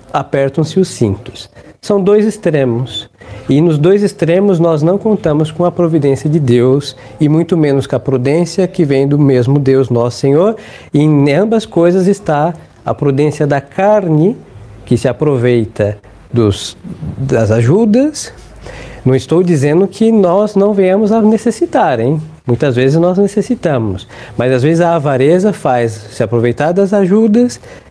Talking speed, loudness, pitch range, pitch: 150 wpm, -12 LUFS, 130-190 Hz, 150 Hz